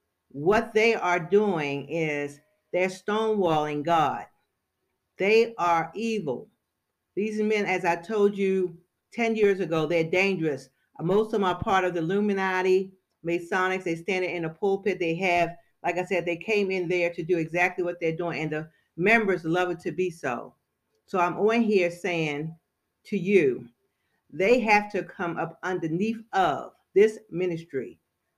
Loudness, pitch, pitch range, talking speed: -26 LUFS, 180 Hz, 170-200 Hz, 160 wpm